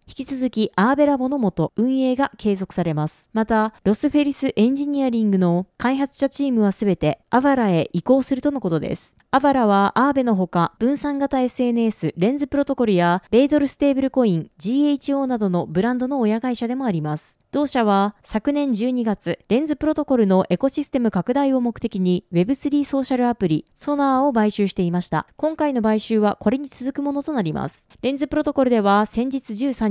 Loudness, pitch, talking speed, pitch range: -20 LUFS, 245 Hz, 400 characters per minute, 200-275 Hz